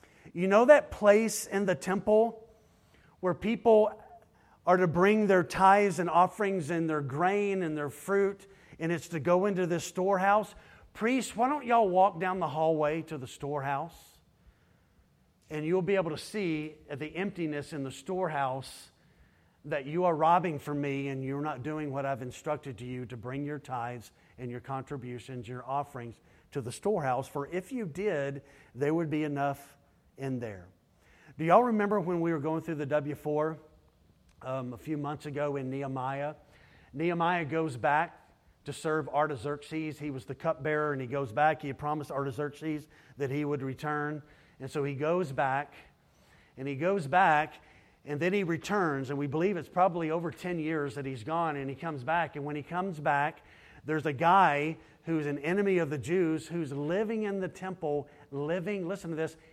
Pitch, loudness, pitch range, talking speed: 155 Hz, -30 LUFS, 140-180 Hz, 180 wpm